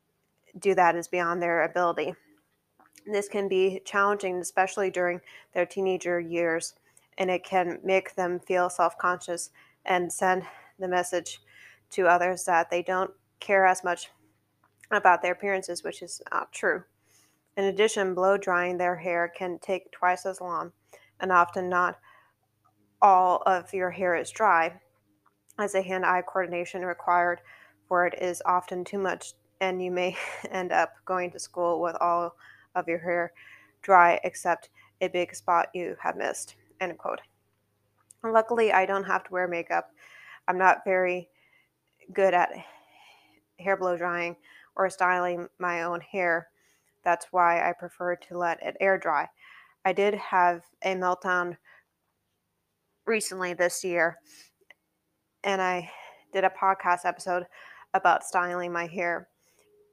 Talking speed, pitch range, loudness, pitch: 140 wpm, 175-190 Hz, -27 LUFS, 180 Hz